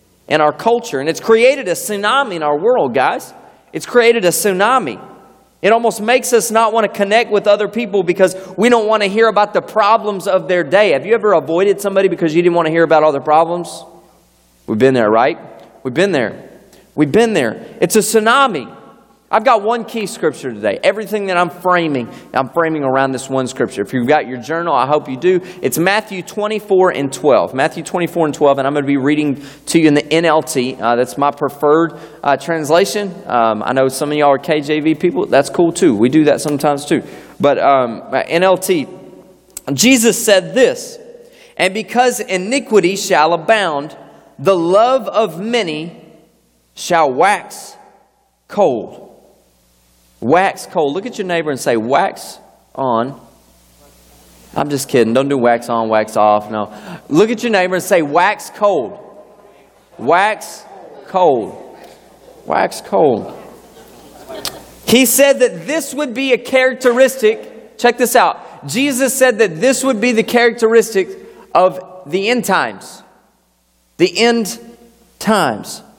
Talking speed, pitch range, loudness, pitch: 165 wpm, 145-225 Hz, -14 LUFS, 185 Hz